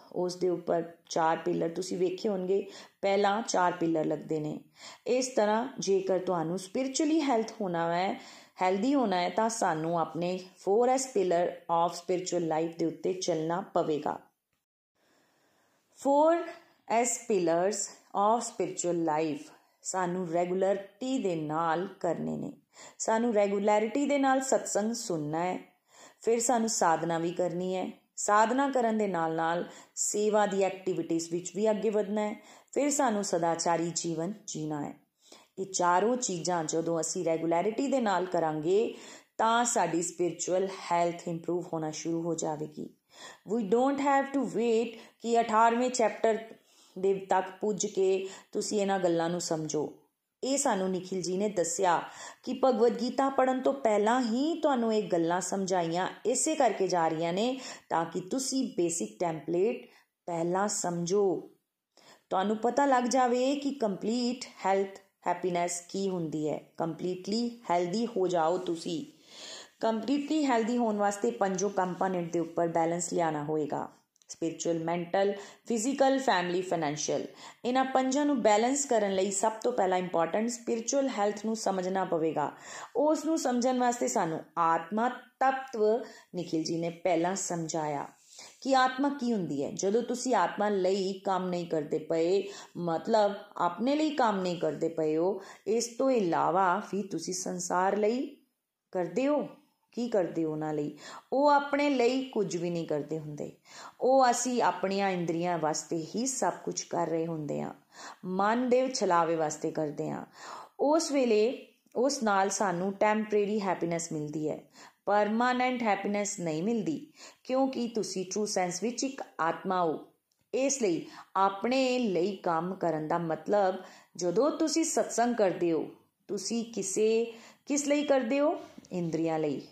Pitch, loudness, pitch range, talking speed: 195 Hz, -30 LUFS, 170-235 Hz, 140 wpm